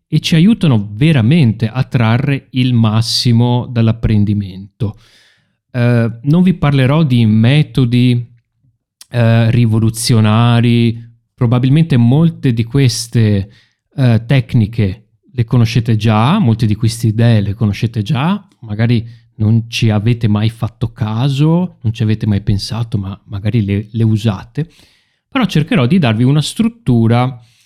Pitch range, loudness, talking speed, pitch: 110-130 Hz, -13 LUFS, 120 wpm, 115 Hz